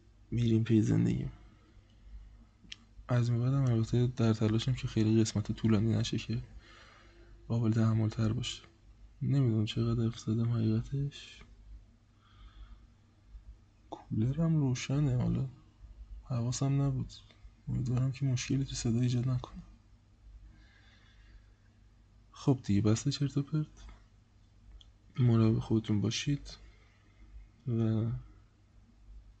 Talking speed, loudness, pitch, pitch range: 90 wpm, -32 LUFS, 110 Hz, 105-120 Hz